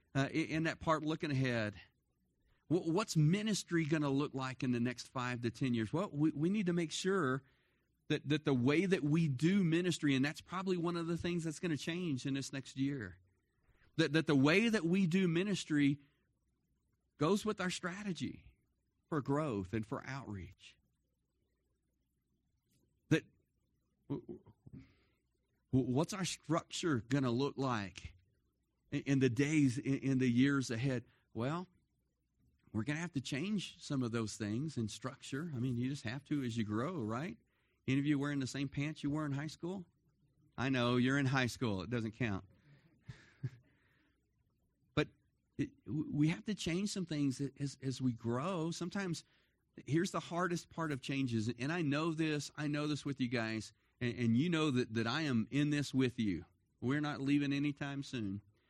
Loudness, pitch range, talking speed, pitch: -37 LUFS, 125-160 Hz, 175 wpm, 140 Hz